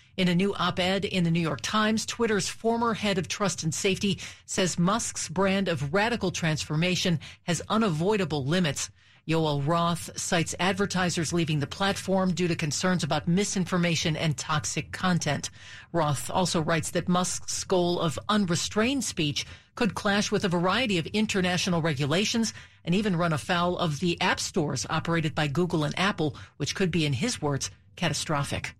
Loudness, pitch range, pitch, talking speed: -27 LUFS, 155-195 Hz, 175 Hz, 160 wpm